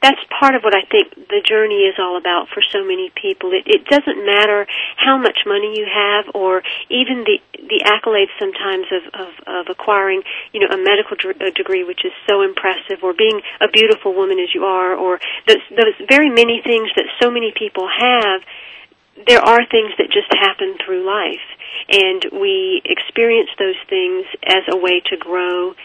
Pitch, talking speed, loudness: 285 Hz, 190 wpm, -15 LUFS